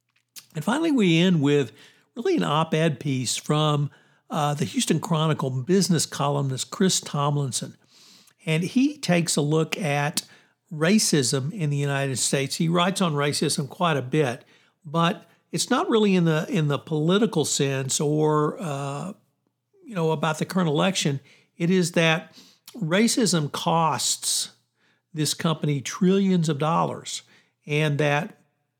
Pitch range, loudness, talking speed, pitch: 145-175 Hz, -23 LUFS, 140 wpm, 155 Hz